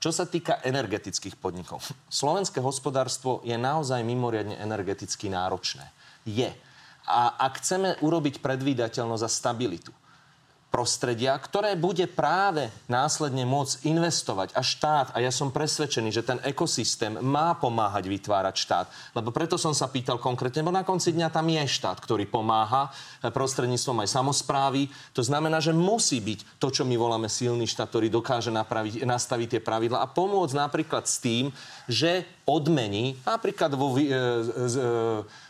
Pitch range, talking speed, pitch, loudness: 115-155 Hz, 145 wpm, 130 Hz, -27 LUFS